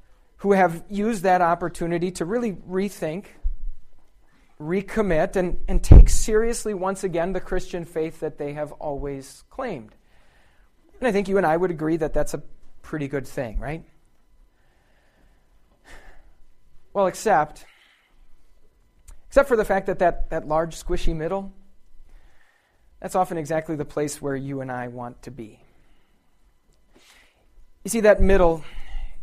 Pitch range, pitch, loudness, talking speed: 145-190 Hz, 170 Hz, -23 LUFS, 135 wpm